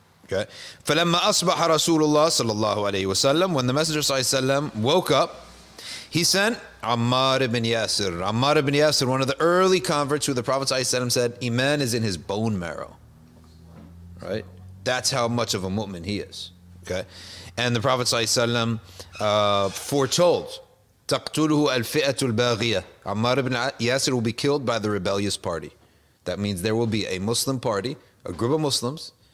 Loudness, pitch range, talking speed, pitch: -23 LUFS, 105-145 Hz, 145 wpm, 120 Hz